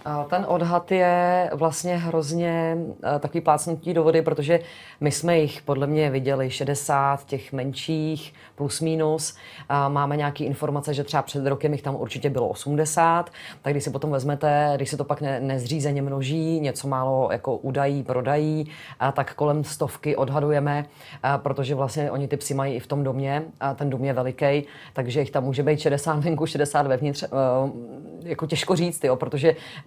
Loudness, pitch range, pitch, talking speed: -24 LUFS, 140-155 Hz, 145 Hz, 170 wpm